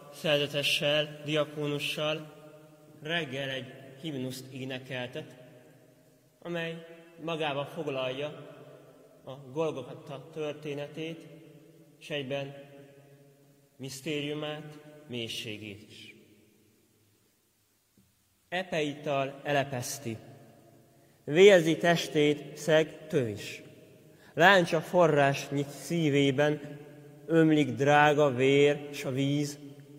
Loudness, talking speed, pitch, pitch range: -28 LUFS, 65 wpm, 145 Hz, 135-155 Hz